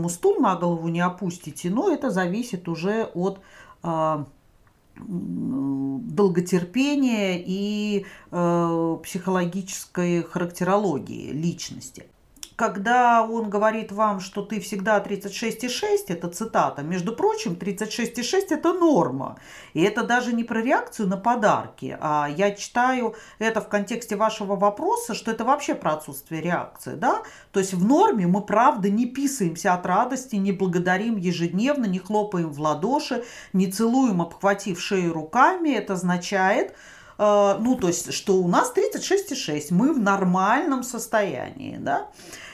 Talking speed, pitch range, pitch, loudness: 125 wpm, 180-235 Hz, 200 Hz, -23 LUFS